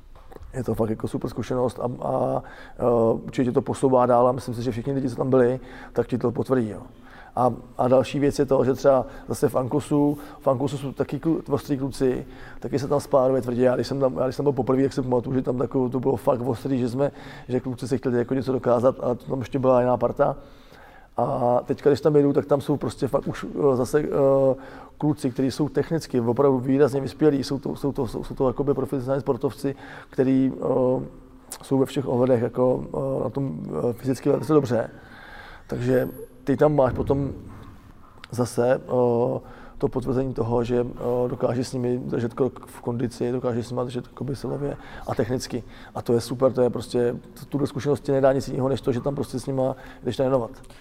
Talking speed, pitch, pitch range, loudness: 205 wpm, 130 Hz, 125-140 Hz, -24 LUFS